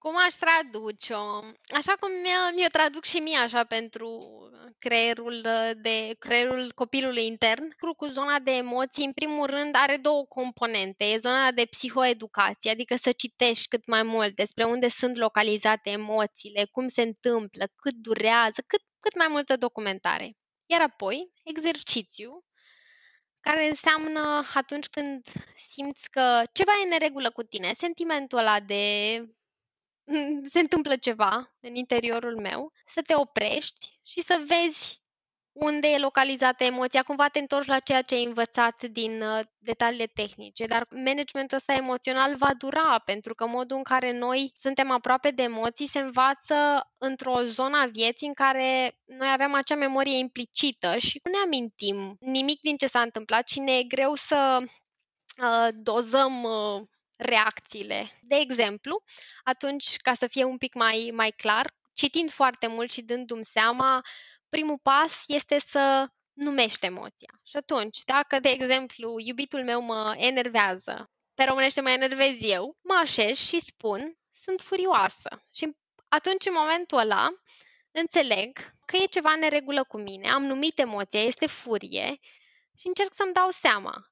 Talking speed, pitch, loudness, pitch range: 150 wpm, 260 Hz, -25 LUFS, 230-290 Hz